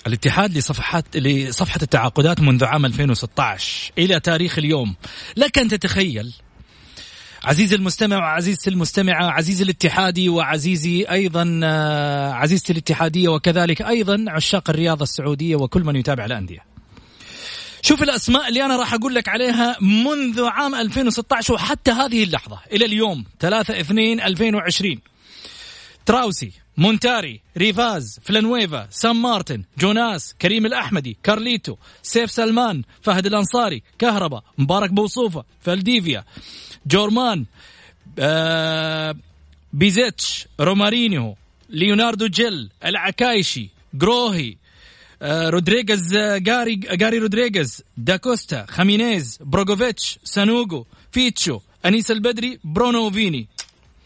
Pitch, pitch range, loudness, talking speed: 185 Hz, 150-225 Hz, -18 LUFS, 95 wpm